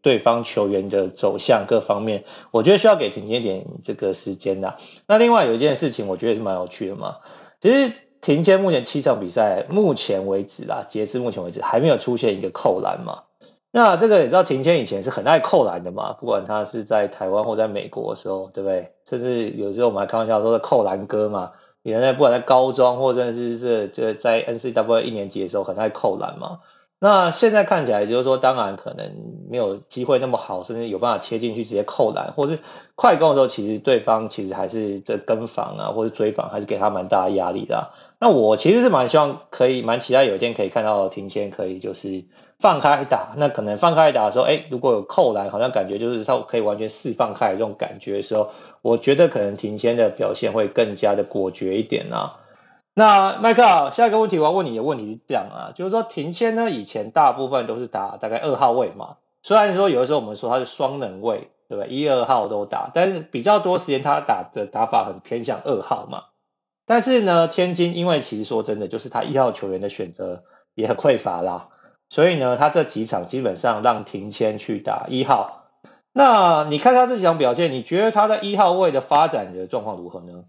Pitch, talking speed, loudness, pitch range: 125 Hz, 335 characters per minute, -20 LUFS, 105-175 Hz